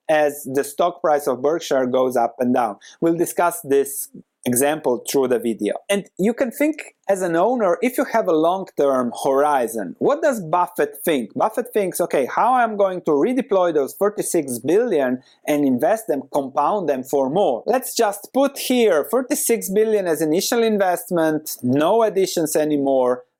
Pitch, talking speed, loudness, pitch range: 170 Hz, 170 wpm, -20 LUFS, 140-210 Hz